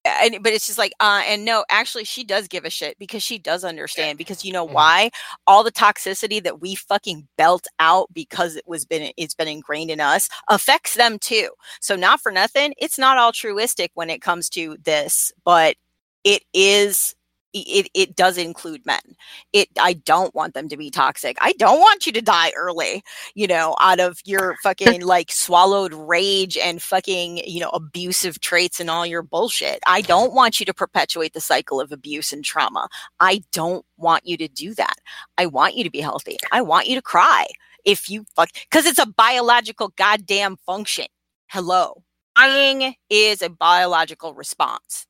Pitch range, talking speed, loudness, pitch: 170-230 Hz, 190 wpm, -18 LUFS, 190 Hz